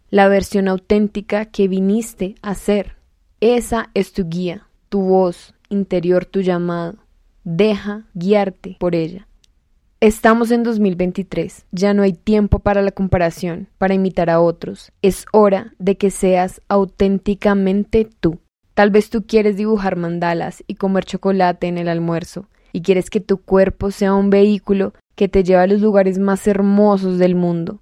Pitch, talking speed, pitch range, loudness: 195 Hz, 155 wpm, 185-205 Hz, -17 LUFS